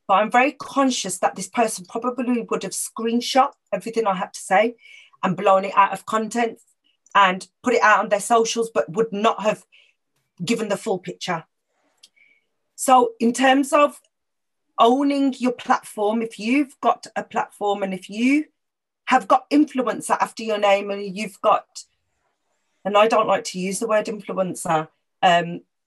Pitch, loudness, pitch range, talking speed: 220 Hz, -21 LUFS, 195-245 Hz, 165 wpm